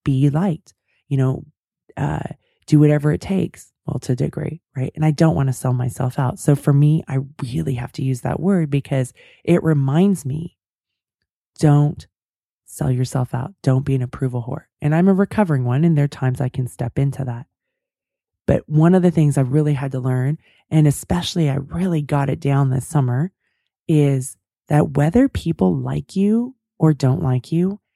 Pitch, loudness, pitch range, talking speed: 145 Hz, -19 LUFS, 130-165 Hz, 185 wpm